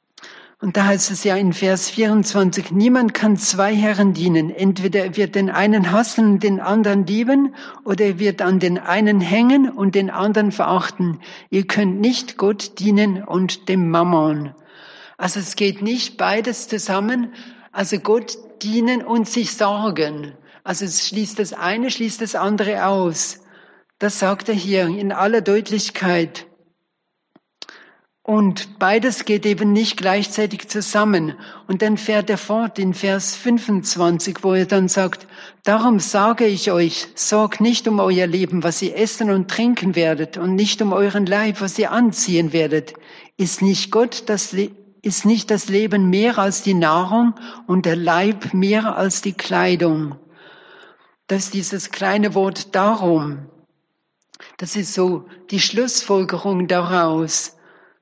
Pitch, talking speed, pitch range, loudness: 200 Hz, 150 wpm, 185-215 Hz, -18 LUFS